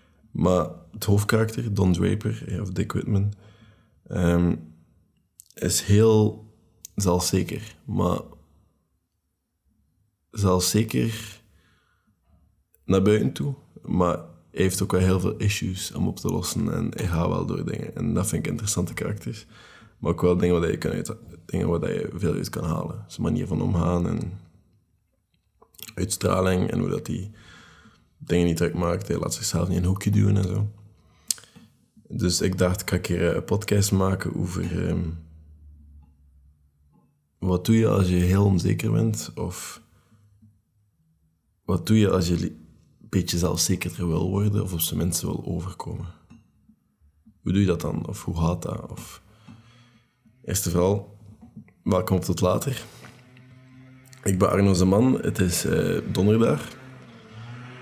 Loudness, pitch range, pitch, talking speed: -24 LUFS, 85-105 Hz, 95 Hz, 145 wpm